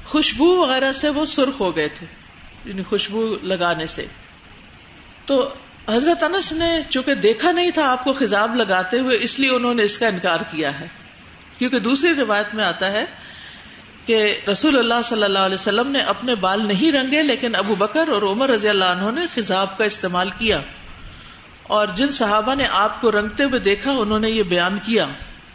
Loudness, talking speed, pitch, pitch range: -19 LUFS, 185 wpm, 220 Hz, 195-270 Hz